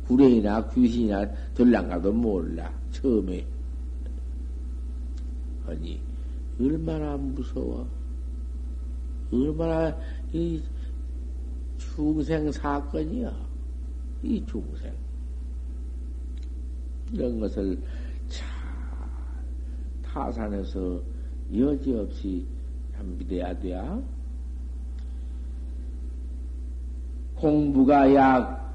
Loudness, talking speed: -28 LUFS, 125 characters per minute